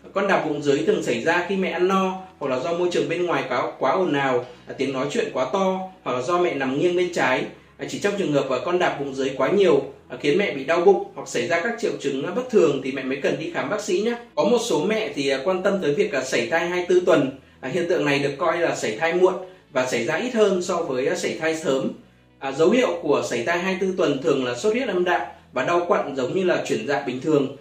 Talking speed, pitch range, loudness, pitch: 265 wpm, 140-195 Hz, -22 LUFS, 175 Hz